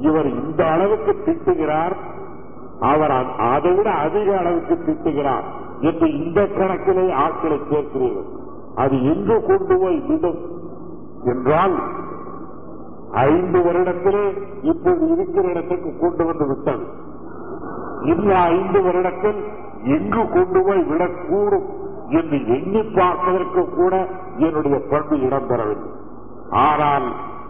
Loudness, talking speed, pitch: -19 LUFS, 95 wpm, 200 Hz